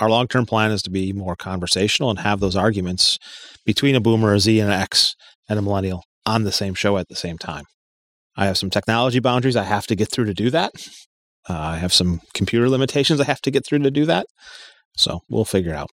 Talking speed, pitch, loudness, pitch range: 235 wpm, 105 Hz, -19 LUFS, 95-125 Hz